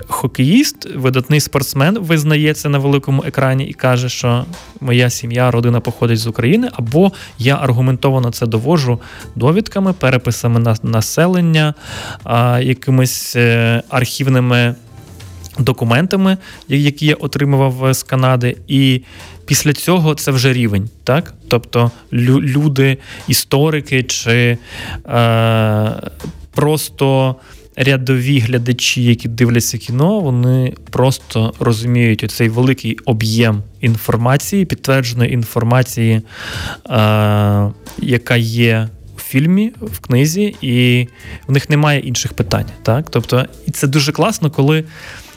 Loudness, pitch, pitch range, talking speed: -14 LUFS, 125 Hz, 115-140 Hz, 105 wpm